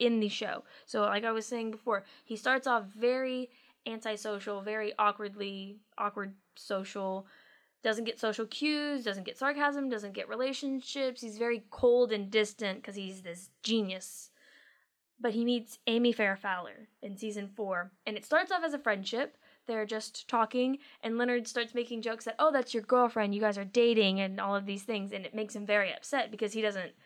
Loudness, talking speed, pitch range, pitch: -33 LUFS, 185 wpm, 205-245 Hz, 220 Hz